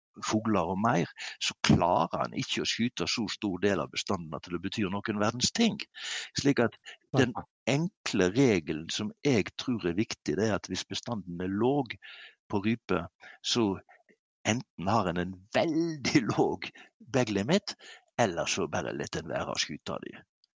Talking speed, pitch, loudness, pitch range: 165 wpm, 110 Hz, -30 LUFS, 100-140 Hz